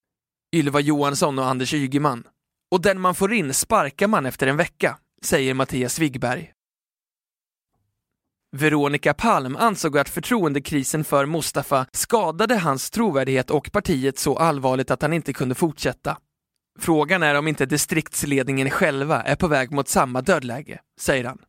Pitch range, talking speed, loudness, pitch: 135-175 Hz, 140 wpm, -21 LUFS, 145 Hz